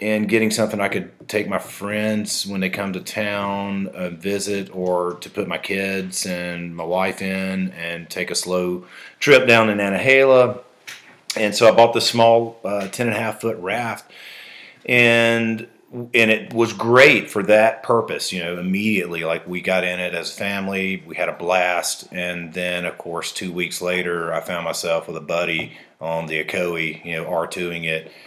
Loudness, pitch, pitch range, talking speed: -20 LUFS, 95 Hz, 90-110 Hz, 185 wpm